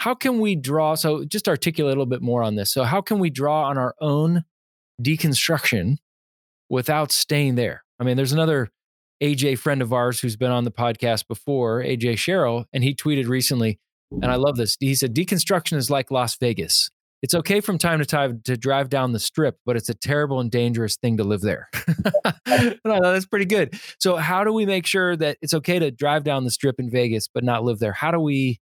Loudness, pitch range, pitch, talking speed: -21 LUFS, 120-160 Hz, 140 Hz, 220 wpm